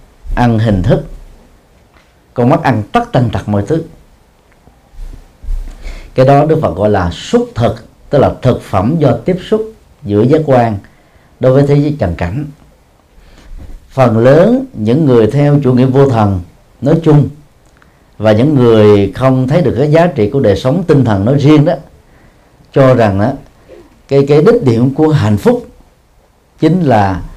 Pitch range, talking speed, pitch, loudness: 105-150 Hz, 165 wpm, 130 Hz, -10 LUFS